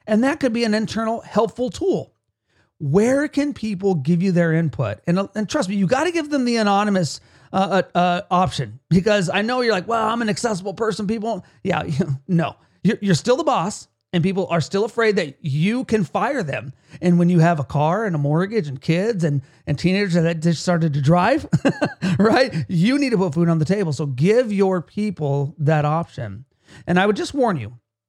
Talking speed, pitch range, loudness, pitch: 210 wpm, 155-215 Hz, -20 LUFS, 185 Hz